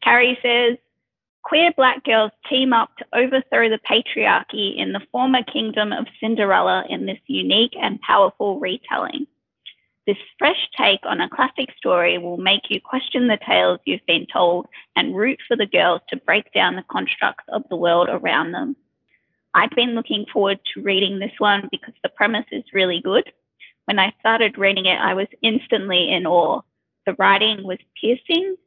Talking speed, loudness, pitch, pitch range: 170 wpm, -19 LUFS, 225 Hz, 195-255 Hz